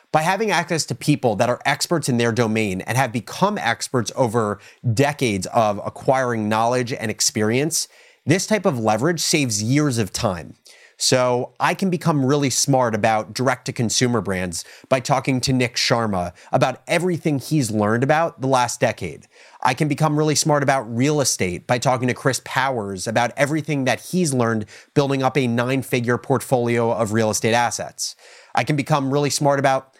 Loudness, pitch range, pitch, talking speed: -20 LUFS, 115-145 Hz, 130 Hz, 175 wpm